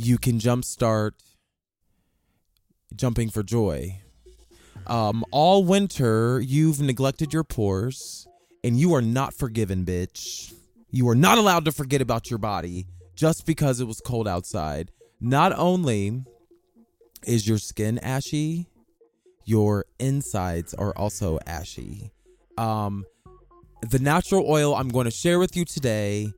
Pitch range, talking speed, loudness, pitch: 105-150 Hz, 130 wpm, -24 LUFS, 120 Hz